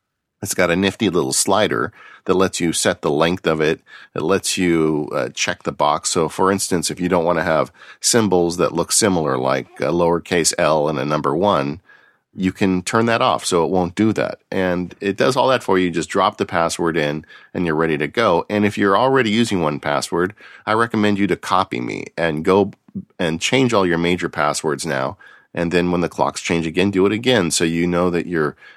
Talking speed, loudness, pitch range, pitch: 225 wpm, -18 LUFS, 85-100 Hz, 90 Hz